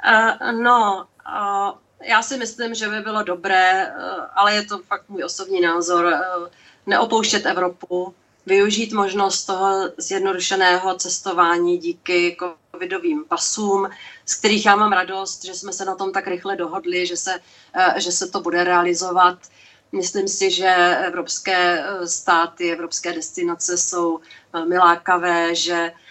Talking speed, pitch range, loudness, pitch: 125 wpm, 175-200 Hz, -19 LUFS, 185 Hz